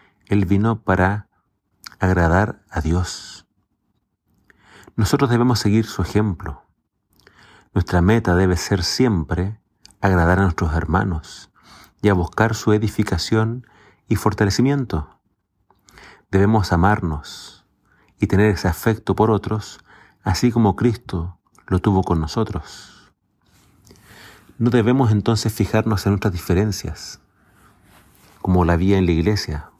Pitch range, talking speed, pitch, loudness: 90-110 Hz, 110 wpm, 100 Hz, -19 LUFS